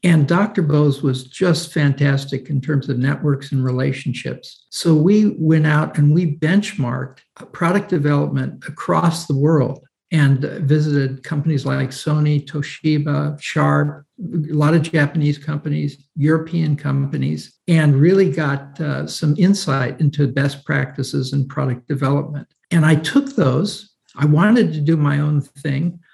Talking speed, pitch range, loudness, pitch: 140 wpm, 140-160 Hz, -18 LUFS, 150 Hz